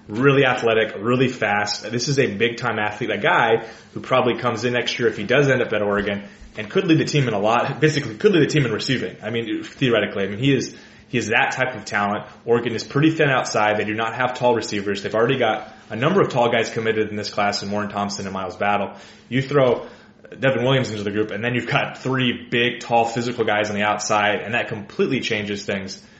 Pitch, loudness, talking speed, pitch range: 115 Hz, -20 LUFS, 245 wpm, 105-130 Hz